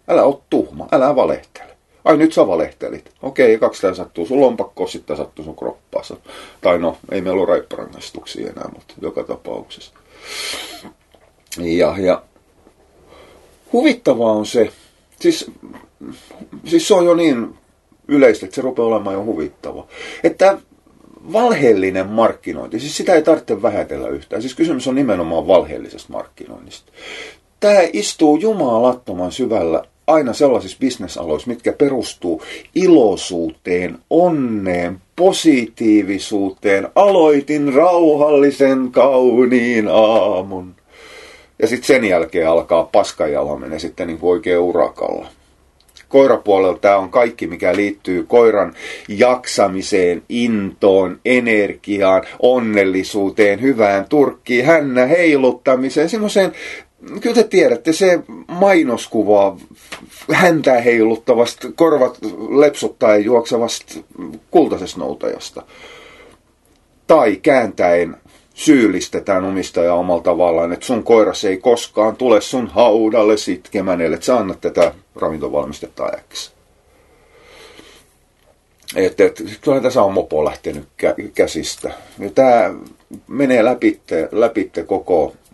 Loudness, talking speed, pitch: -15 LUFS, 105 wpm, 125 Hz